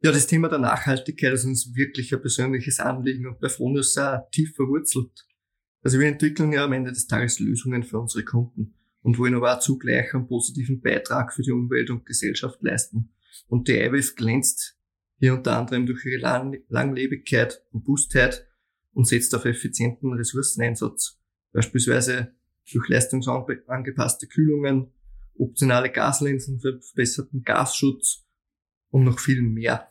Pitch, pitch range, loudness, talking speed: 130 Hz, 120-135 Hz, -23 LUFS, 145 wpm